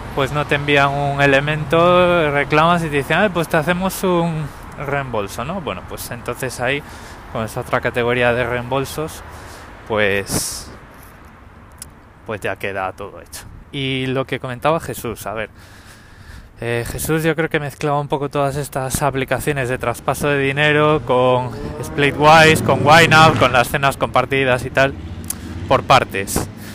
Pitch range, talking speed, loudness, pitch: 110-150 Hz, 150 wpm, -17 LUFS, 130 Hz